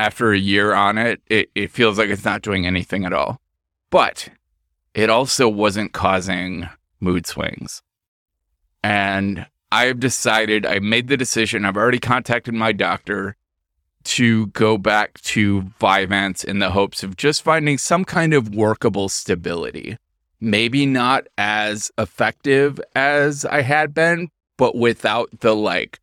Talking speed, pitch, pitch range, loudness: 145 wpm, 105 Hz, 95-120 Hz, -18 LUFS